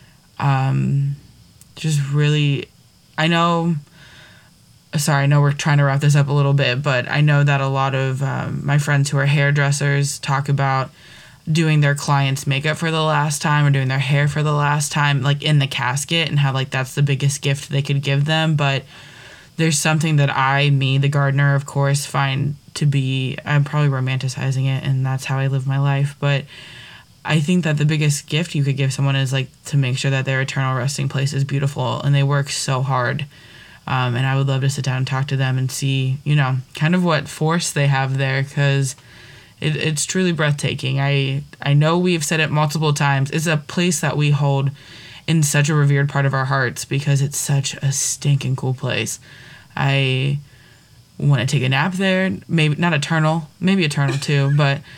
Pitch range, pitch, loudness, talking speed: 135-150 Hz, 140 Hz, -18 LUFS, 205 wpm